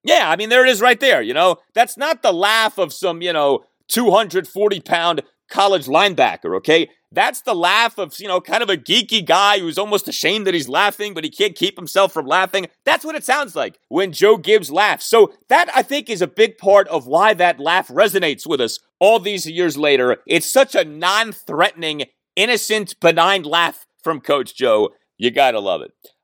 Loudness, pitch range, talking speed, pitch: -16 LUFS, 175-260 Hz, 205 wpm, 205 Hz